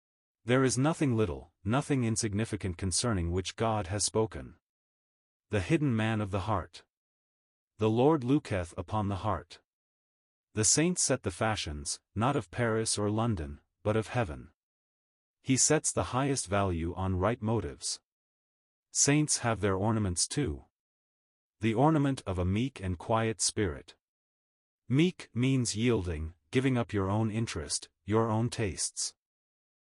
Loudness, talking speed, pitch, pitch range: -30 LUFS, 135 wpm, 110 Hz, 95-120 Hz